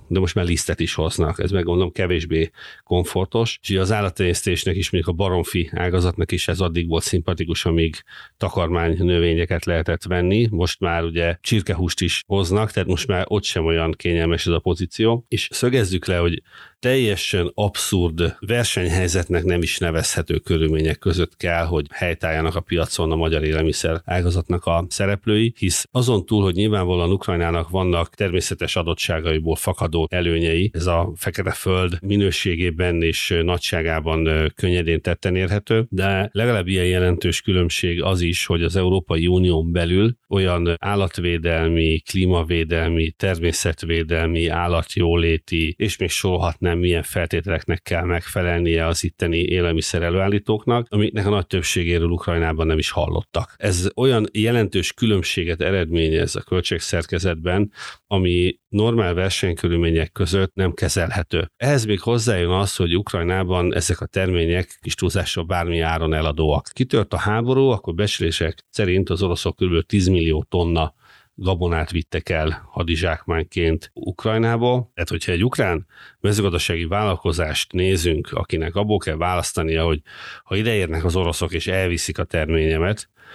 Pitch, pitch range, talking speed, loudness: 90 Hz, 85-100 Hz, 135 wpm, -21 LUFS